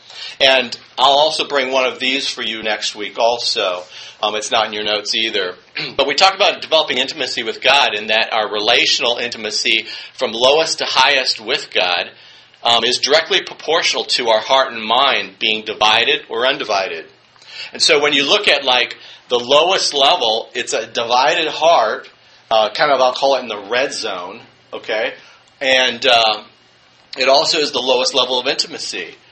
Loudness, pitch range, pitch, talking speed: -15 LUFS, 110-140 Hz, 120 Hz, 175 wpm